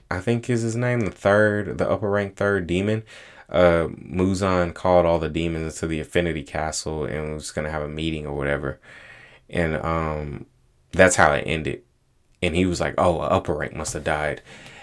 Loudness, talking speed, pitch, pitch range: -23 LUFS, 185 wpm, 85 Hz, 75-95 Hz